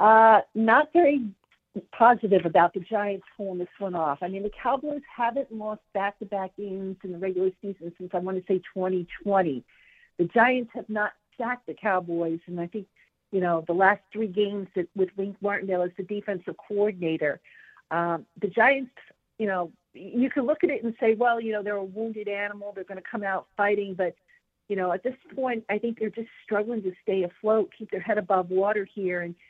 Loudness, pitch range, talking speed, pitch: -26 LUFS, 185-220 Hz, 200 wpm, 205 Hz